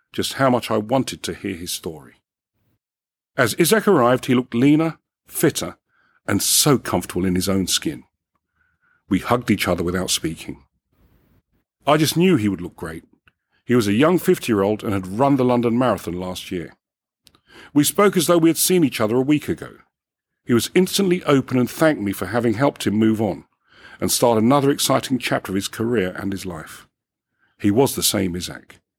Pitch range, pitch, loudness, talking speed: 100-150 Hz, 120 Hz, -19 LUFS, 190 wpm